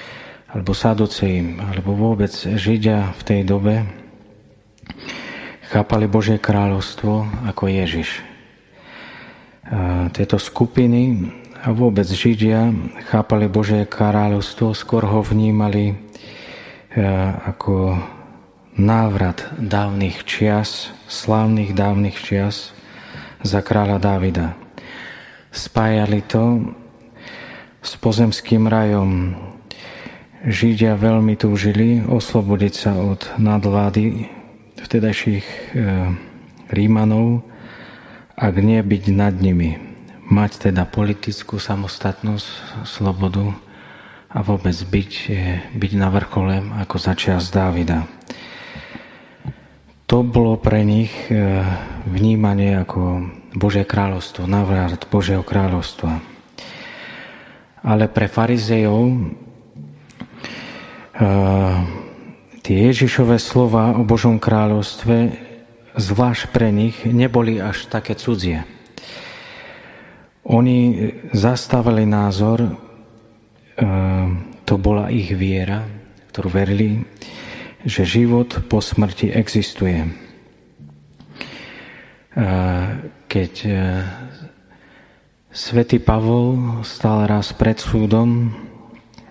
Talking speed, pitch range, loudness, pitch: 80 wpm, 95-115 Hz, -18 LUFS, 105 Hz